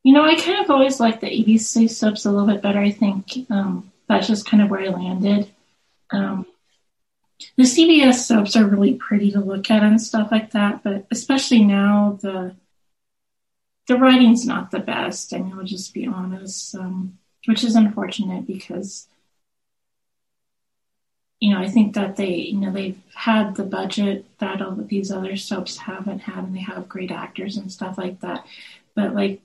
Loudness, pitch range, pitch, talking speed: -19 LUFS, 195-225 Hz, 205 Hz, 180 wpm